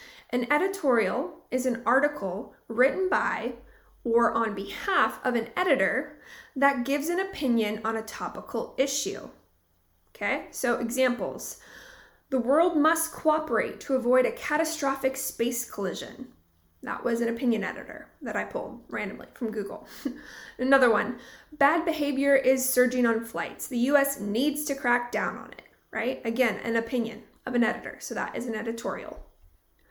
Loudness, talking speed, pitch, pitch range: -27 LUFS, 145 wpm, 250 Hz, 230-280 Hz